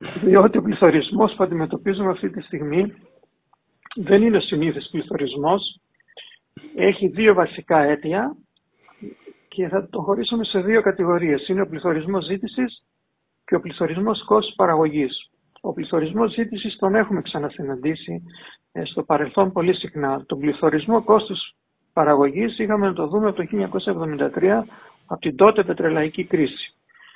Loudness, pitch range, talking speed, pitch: -20 LUFS, 160-215 Hz, 125 wpm, 190 Hz